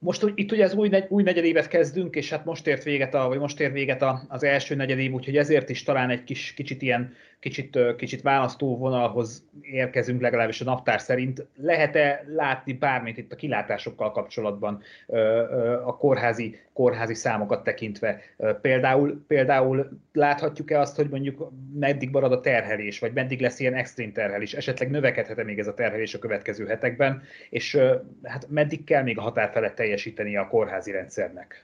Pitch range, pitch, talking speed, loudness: 125-150 Hz, 135 Hz, 170 wpm, -25 LUFS